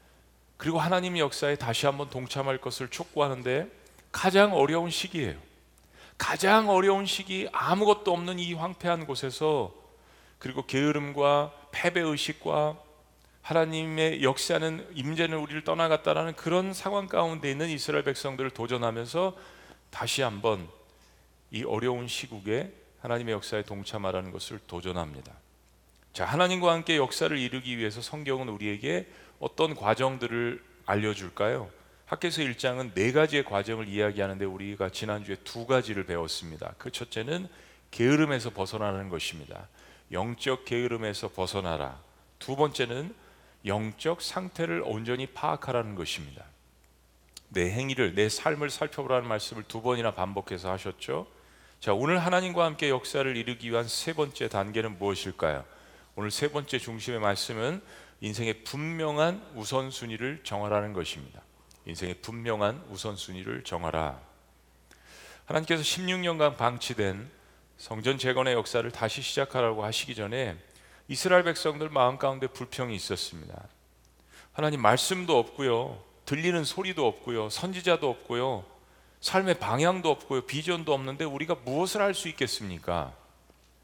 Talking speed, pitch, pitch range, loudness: 325 characters per minute, 125 Hz, 100-155 Hz, -29 LUFS